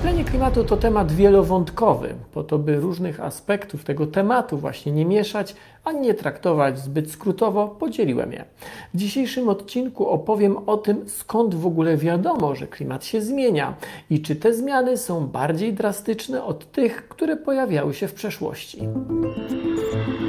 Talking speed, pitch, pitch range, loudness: 150 wpm, 200 Hz, 155-225 Hz, -22 LUFS